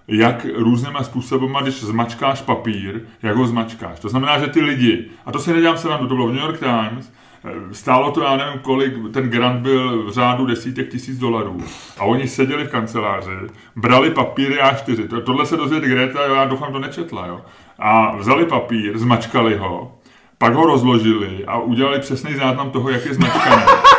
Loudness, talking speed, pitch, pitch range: -17 LUFS, 190 wpm, 125 Hz, 115-135 Hz